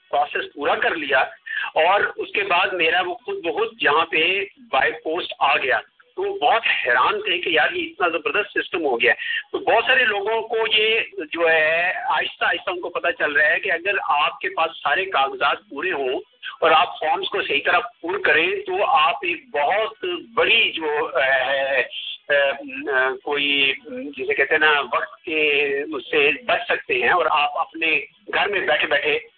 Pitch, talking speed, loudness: 385 Hz, 190 wpm, -20 LUFS